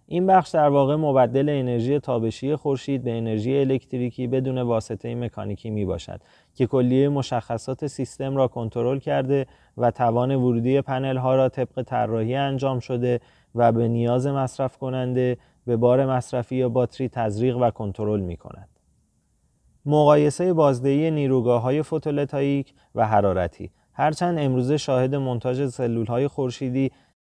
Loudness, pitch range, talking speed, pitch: -23 LUFS, 120-140 Hz, 135 wpm, 130 Hz